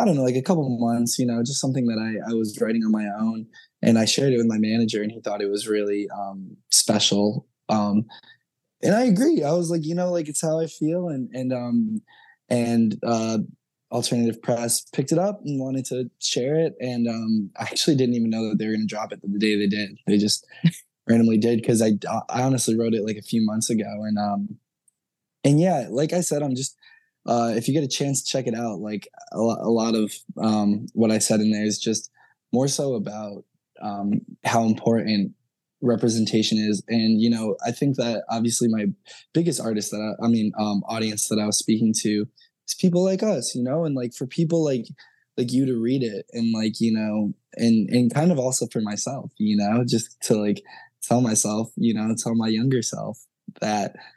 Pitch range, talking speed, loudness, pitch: 110-135 Hz, 220 wpm, -23 LUFS, 115 Hz